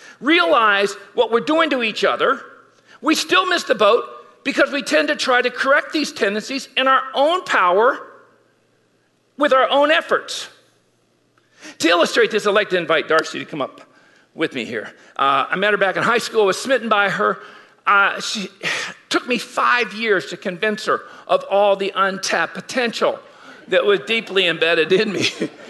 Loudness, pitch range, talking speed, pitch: -18 LUFS, 200-290 Hz, 175 wpm, 235 Hz